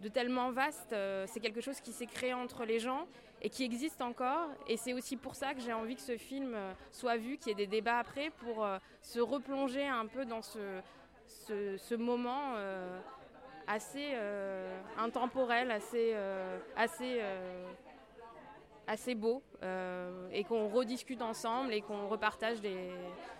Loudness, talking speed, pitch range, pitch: -38 LUFS, 170 wpm, 210-255 Hz, 230 Hz